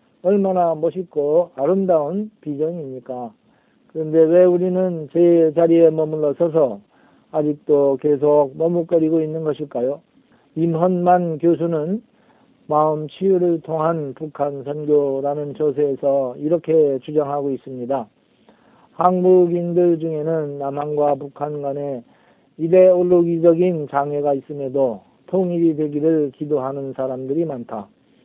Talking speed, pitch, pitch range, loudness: 265 characters per minute, 155 Hz, 145-175 Hz, -19 LUFS